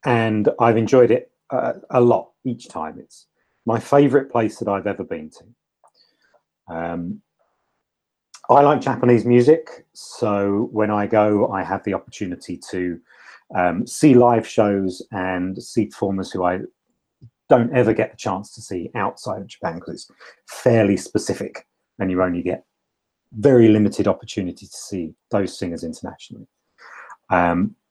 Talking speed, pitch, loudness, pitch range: 145 wpm, 105 Hz, -19 LUFS, 95-120 Hz